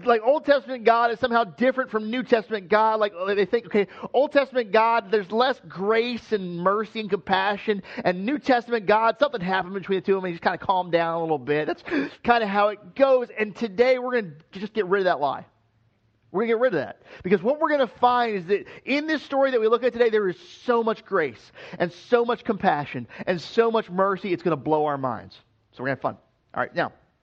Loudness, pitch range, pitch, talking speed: -23 LUFS, 185-240 Hz, 215 Hz, 250 wpm